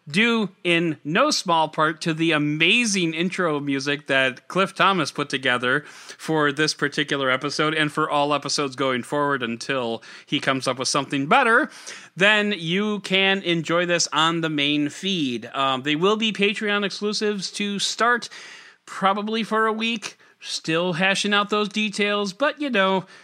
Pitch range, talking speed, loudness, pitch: 145-205 Hz, 155 wpm, -21 LUFS, 170 Hz